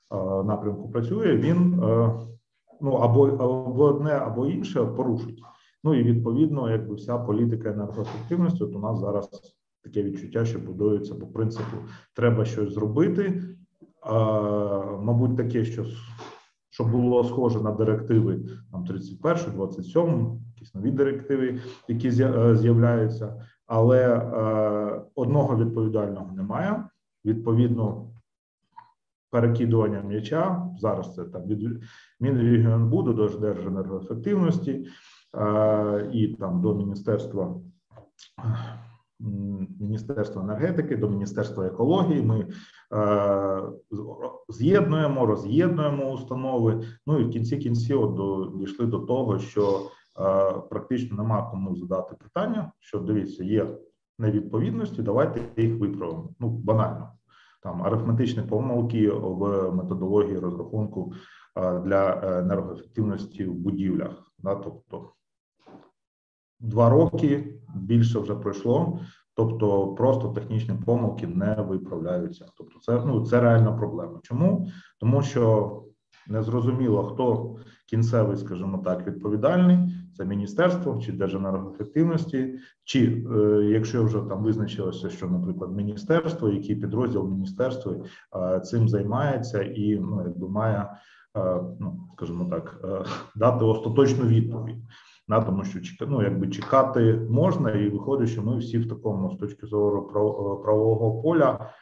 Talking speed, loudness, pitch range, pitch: 110 wpm, -25 LUFS, 100-125 Hz, 110 Hz